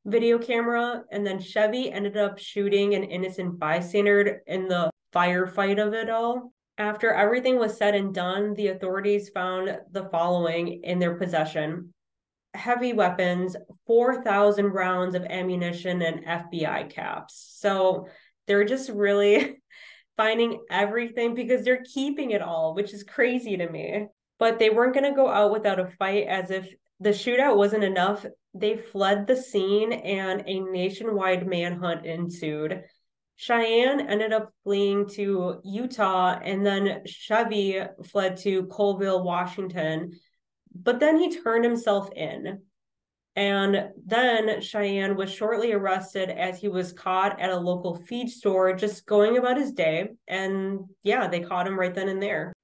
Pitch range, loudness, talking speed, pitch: 185-220 Hz, -25 LUFS, 145 wpm, 200 Hz